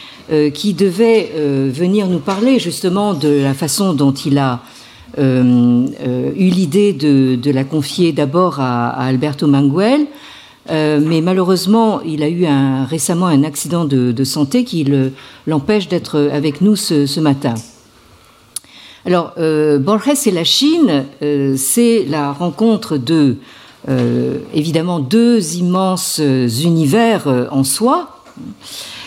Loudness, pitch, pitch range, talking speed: -14 LUFS, 155 Hz, 140-190 Hz, 140 wpm